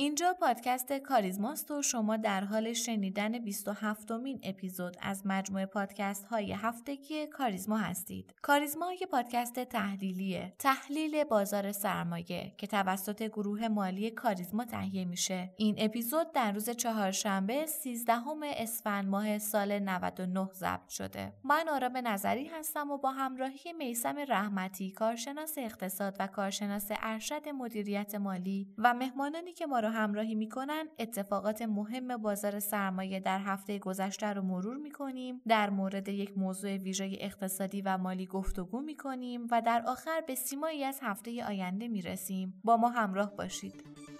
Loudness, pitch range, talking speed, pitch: -34 LUFS, 195-250 Hz, 140 wpm, 215 Hz